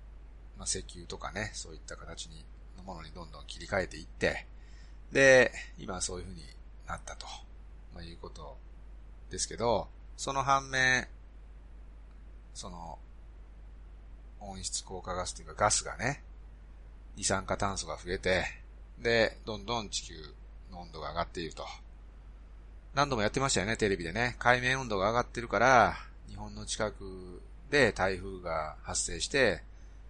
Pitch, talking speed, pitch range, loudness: 90 Hz, 275 characters per minute, 75-105 Hz, -31 LUFS